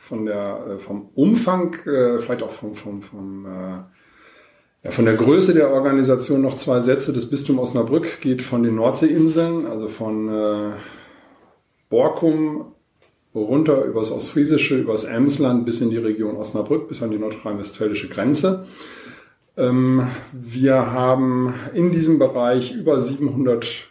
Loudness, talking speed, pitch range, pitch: -19 LUFS, 135 wpm, 110-140 Hz, 125 Hz